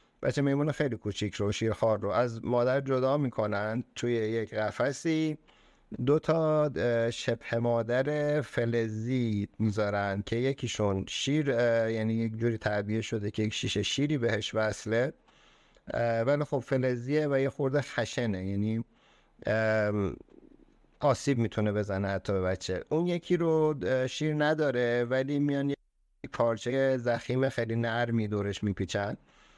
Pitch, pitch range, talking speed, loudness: 115 Hz, 105-135 Hz, 125 wpm, -30 LUFS